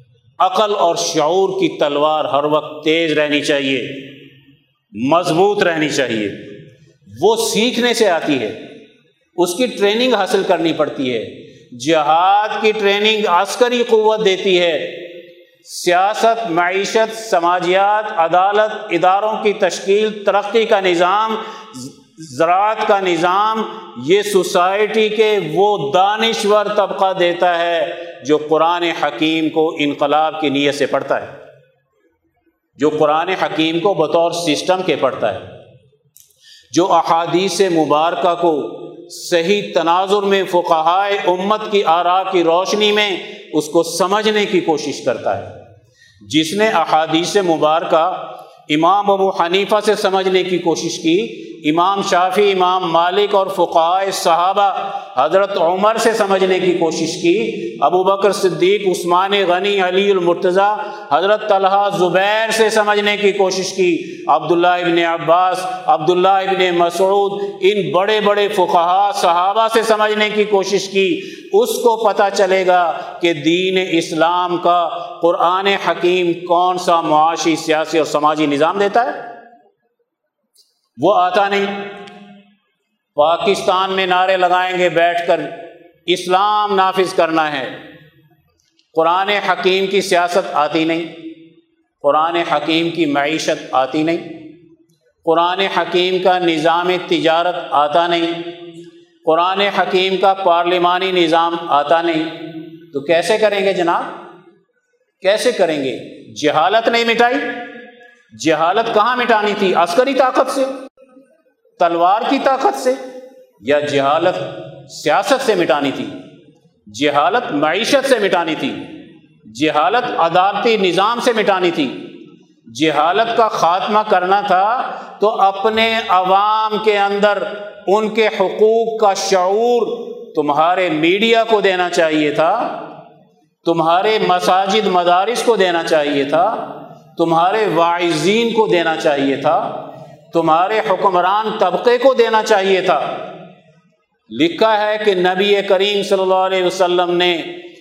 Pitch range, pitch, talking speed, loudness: 170-215 Hz, 185 Hz, 120 wpm, -15 LUFS